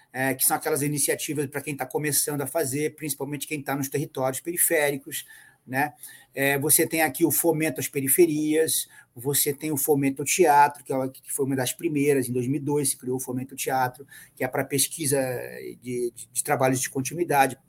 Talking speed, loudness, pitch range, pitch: 190 wpm, -24 LUFS, 130-150 Hz, 140 Hz